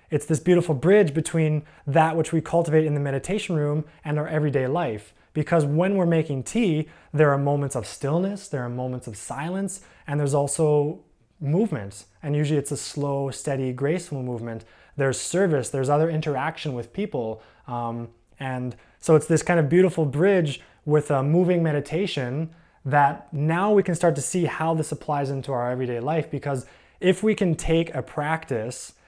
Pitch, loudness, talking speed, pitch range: 150 Hz, -24 LUFS, 175 wpm, 135-165 Hz